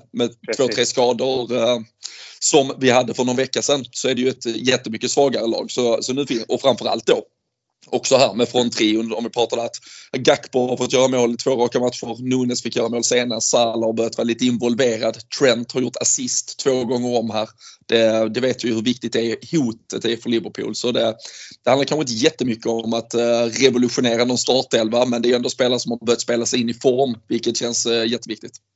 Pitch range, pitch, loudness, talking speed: 115-125 Hz, 120 Hz, -19 LUFS, 215 wpm